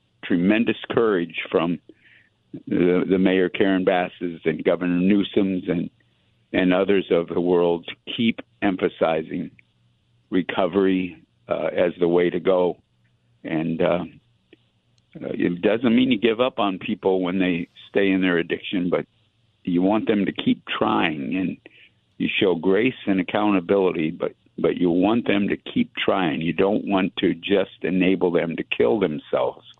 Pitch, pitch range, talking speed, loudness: 95 Hz, 90-100 Hz, 150 wpm, -22 LUFS